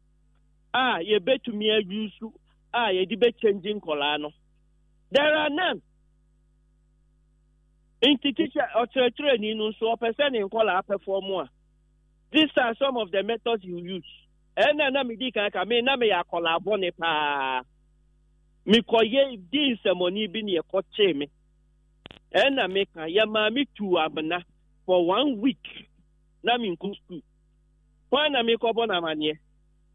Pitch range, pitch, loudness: 150-230 Hz, 195 Hz, -25 LUFS